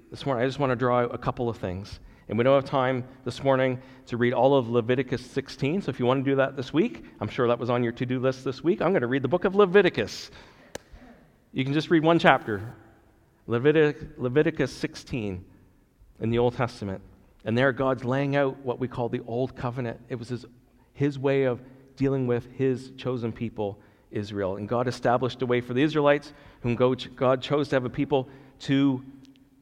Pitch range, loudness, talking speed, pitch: 120-135 Hz, -26 LUFS, 210 wpm, 130 Hz